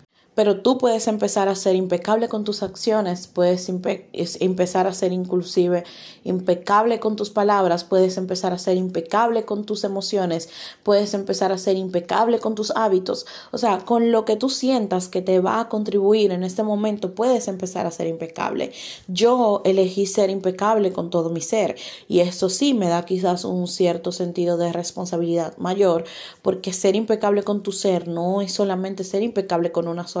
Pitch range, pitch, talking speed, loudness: 180-210 Hz, 190 Hz, 180 wpm, -21 LUFS